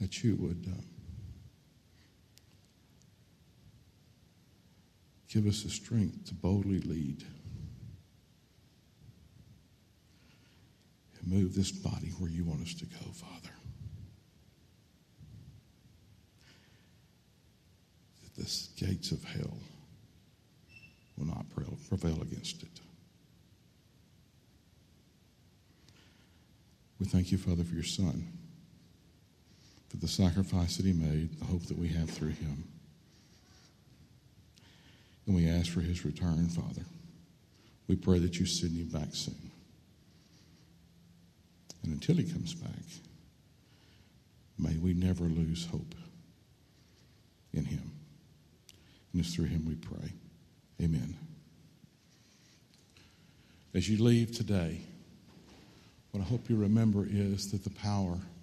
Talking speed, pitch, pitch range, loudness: 100 wpm, 90 Hz, 85-100 Hz, -34 LUFS